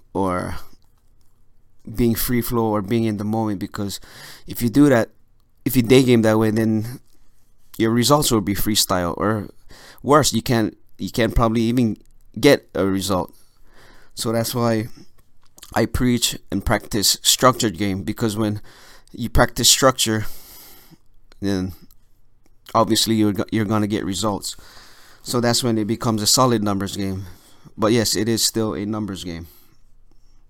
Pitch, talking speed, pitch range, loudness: 110 Hz, 150 wpm, 105-115 Hz, -19 LUFS